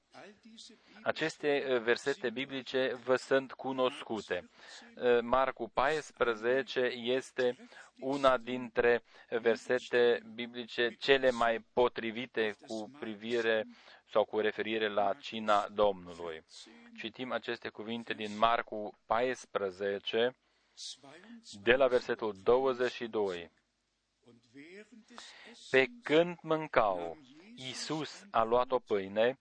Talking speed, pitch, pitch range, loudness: 85 wpm, 120 Hz, 115-130 Hz, -32 LUFS